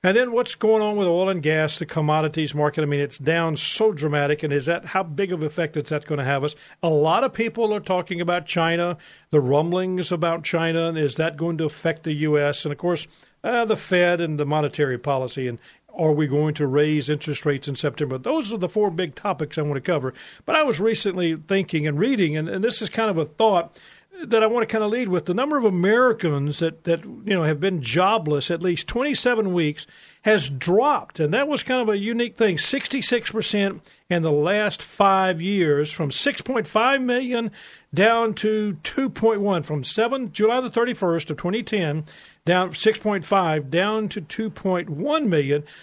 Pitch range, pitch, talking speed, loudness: 155-215 Hz, 175 Hz, 215 wpm, -22 LUFS